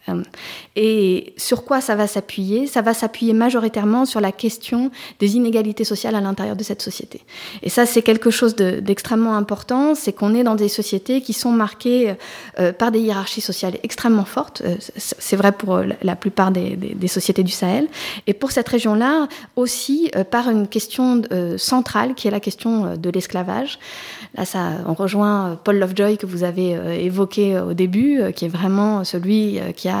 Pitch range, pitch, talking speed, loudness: 195-240 Hz, 215 Hz, 170 wpm, -19 LUFS